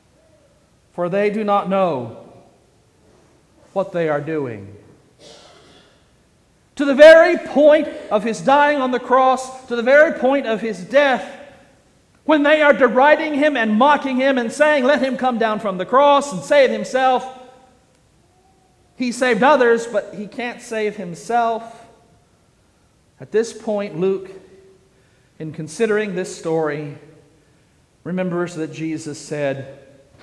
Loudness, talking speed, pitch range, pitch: -17 LUFS, 130 wpm, 170-265 Hz, 220 Hz